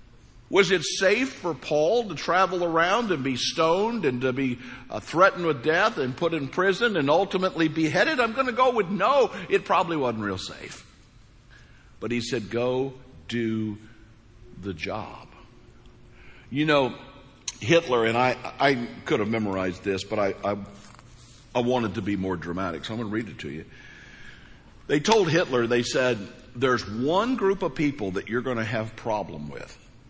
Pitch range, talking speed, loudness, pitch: 110-165 Hz, 175 wpm, -25 LUFS, 125 Hz